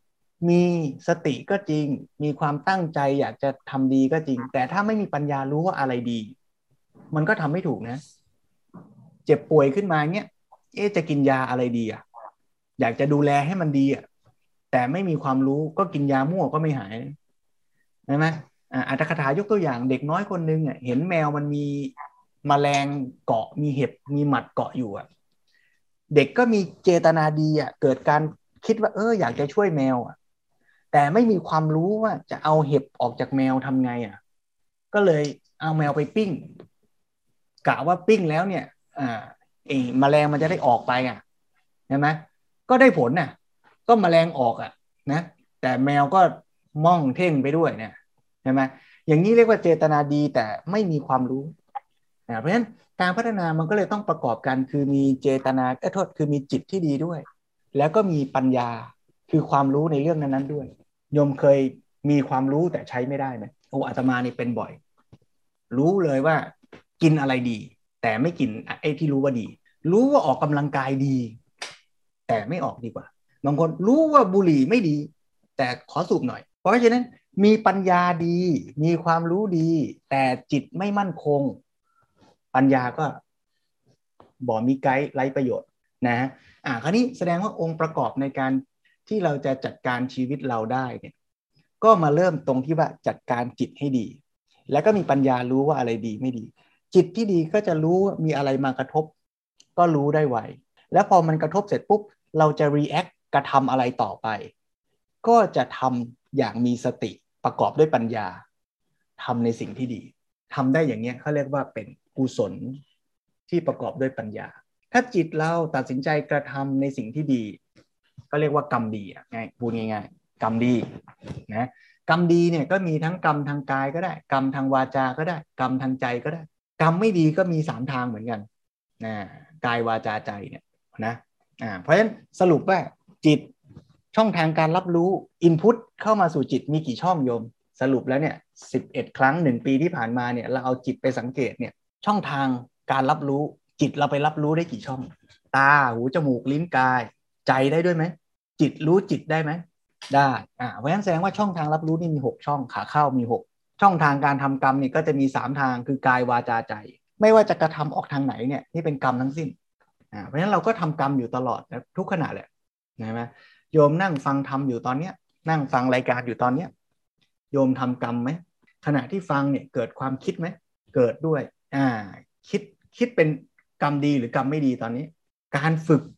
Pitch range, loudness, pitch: 130-165 Hz, -23 LUFS, 145 Hz